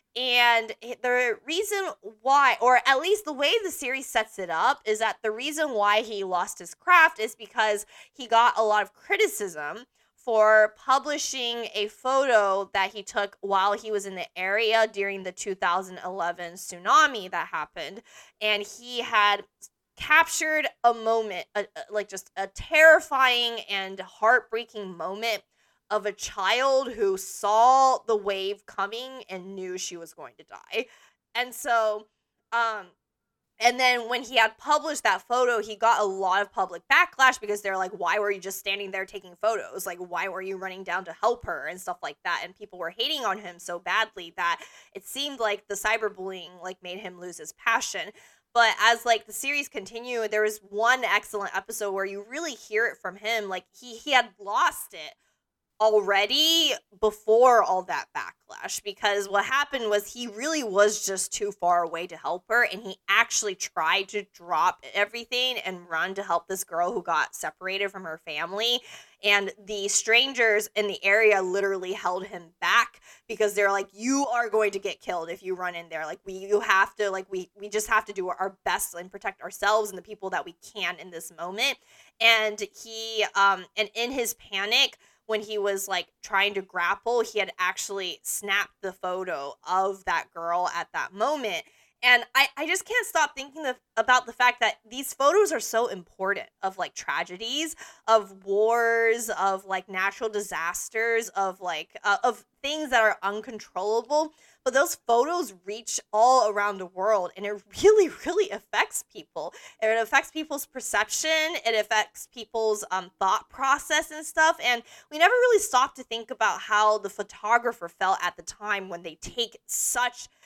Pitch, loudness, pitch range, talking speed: 215 Hz, -25 LUFS, 195-245 Hz, 180 wpm